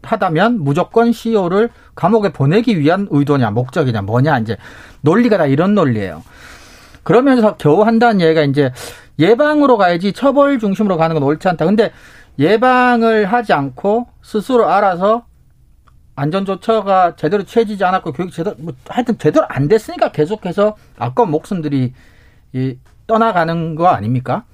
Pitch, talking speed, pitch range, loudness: 180 Hz, 340 characters per minute, 145-225 Hz, -14 LUFS